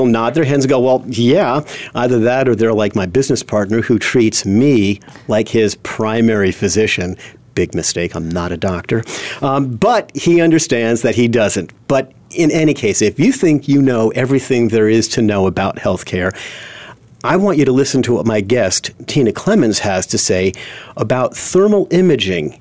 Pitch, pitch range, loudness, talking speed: 115 Hz, 105-135 Hz, -14 LUFS, 180 wpm